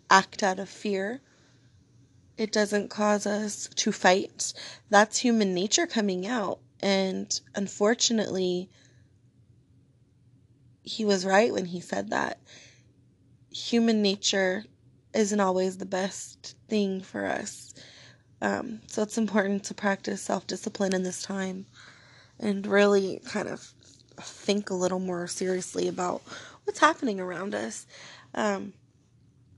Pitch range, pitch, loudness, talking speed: 175-210 Hz, 195 Hz, -27 LUFS, 120 wpm